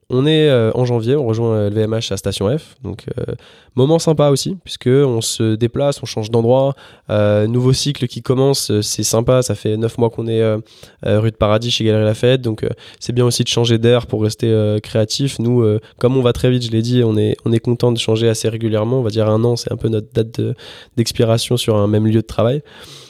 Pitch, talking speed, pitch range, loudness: 115 Hz, 245 wpm, 110-125 Hz, -16 LUFS